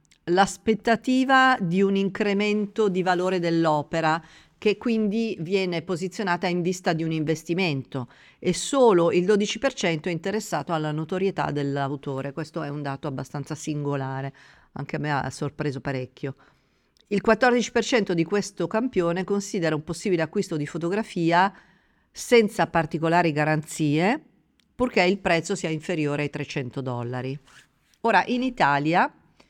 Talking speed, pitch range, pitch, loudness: 125 wpm, 150-200 Hz, 170 Hz, -24 LUFS